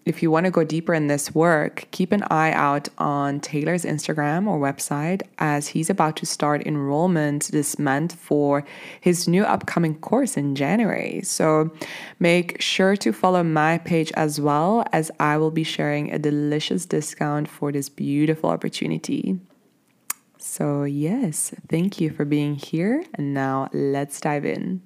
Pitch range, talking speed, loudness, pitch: 145-180 Hz, 160 wpm, -22 LUFS, 155 Hz